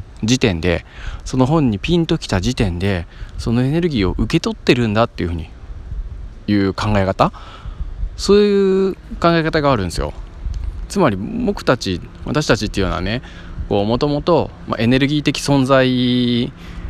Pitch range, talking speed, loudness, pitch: 90-135 Hz, 300 characters per minute, -17 LUFS, 110 Hz